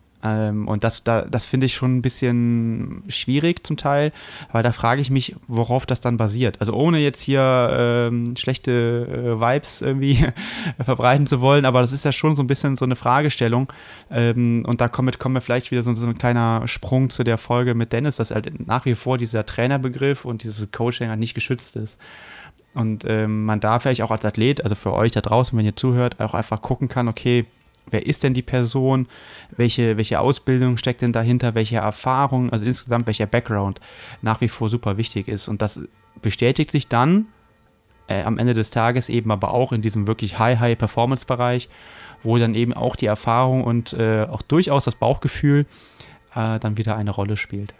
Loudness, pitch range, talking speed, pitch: -20 LUFS, 110-130 Hz, 195 wpm, 120 Hz